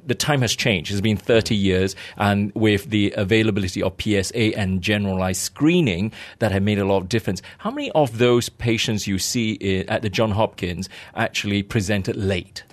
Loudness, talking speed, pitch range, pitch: -21 LUFS, 180 wpm, 95-115 Hz, 105 Hz